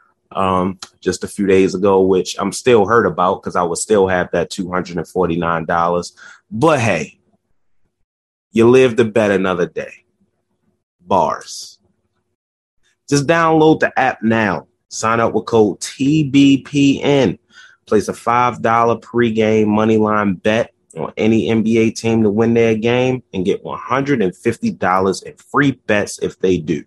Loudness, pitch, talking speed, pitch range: -16 LUFS, 110 Hz, 135 wpm, 95-120 Hz